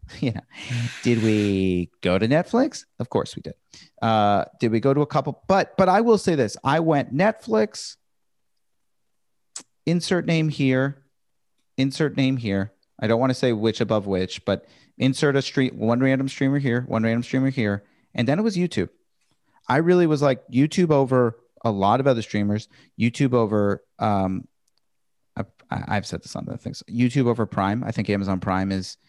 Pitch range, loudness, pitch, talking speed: 105-140 Hz, -22 LUFS, 120 Hz, 180 wpm